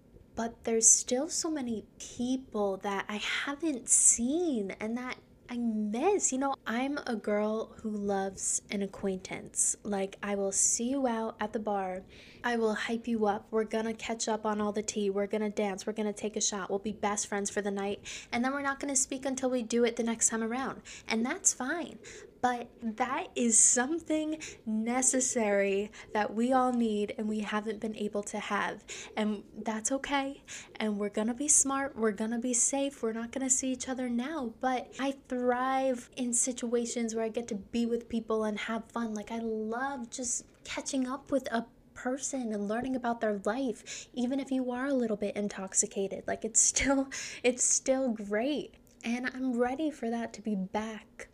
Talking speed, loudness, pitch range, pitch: 195 wpm, -31 LUFS, 215-260 Hz, 230 Hz